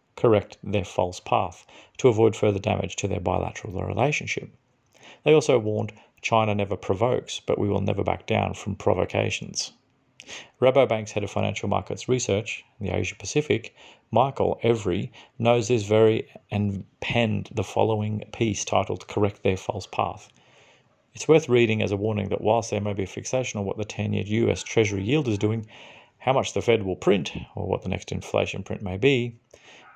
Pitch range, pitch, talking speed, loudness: 100-115 Hz, 105 Hz, 175 wpm, -25 LUFS